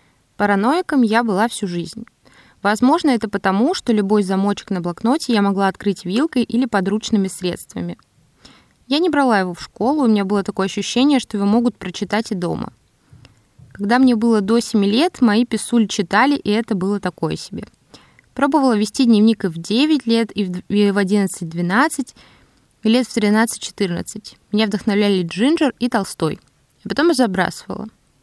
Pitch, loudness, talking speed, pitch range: 210 Hz, -18 LUFS, 155 wpm, 195-240 Hz